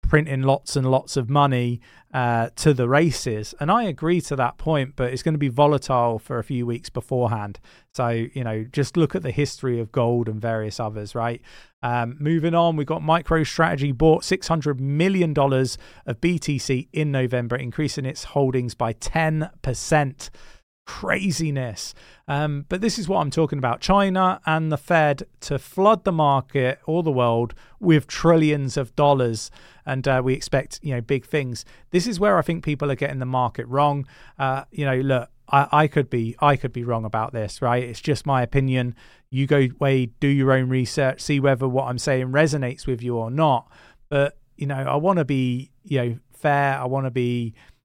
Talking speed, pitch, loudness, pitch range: 190 wpm, 135 Hz, -22 LUFS, 125-150 Hz